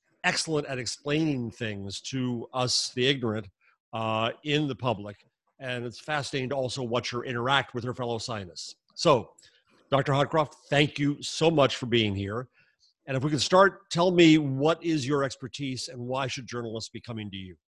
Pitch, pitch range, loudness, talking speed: 130 Hz, 115-145 Hz, -27 LUFS, 180 wpm